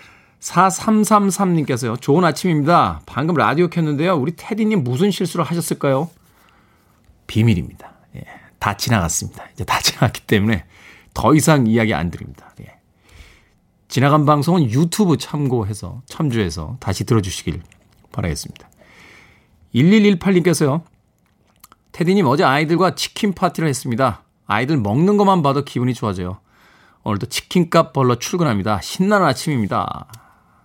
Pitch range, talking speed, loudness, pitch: 105-175 Hz, 310 characters per minute, -17 LUFS, 140 Hz